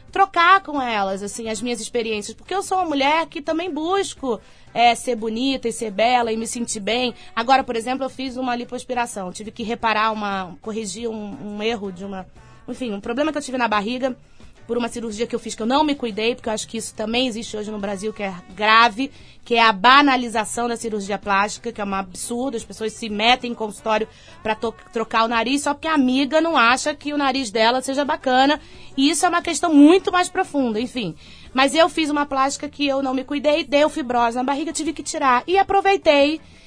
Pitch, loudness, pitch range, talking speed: 245 Hz, -20 LUFS, 225-290 Hz, 225 wpm